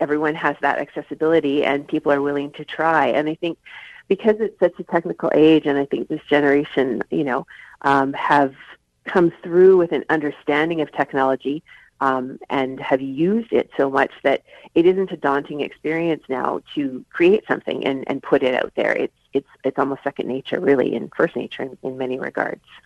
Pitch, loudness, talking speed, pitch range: 150 Hz, -20 LUFS, 190 wpm, 140-170 Hz